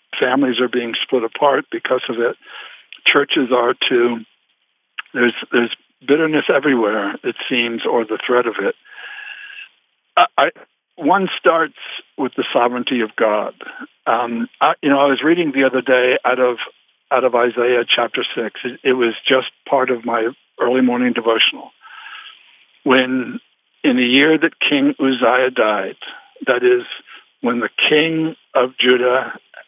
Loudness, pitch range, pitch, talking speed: -17 LUFS, 125-150 Hz, 130 Hz, 150 wpm